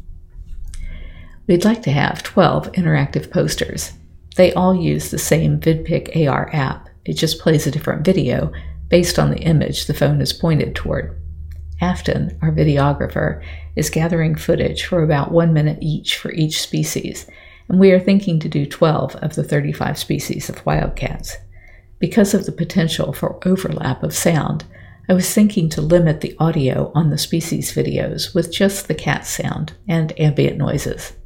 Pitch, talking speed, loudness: 155 Hz, 160 wpm, -18 LUFS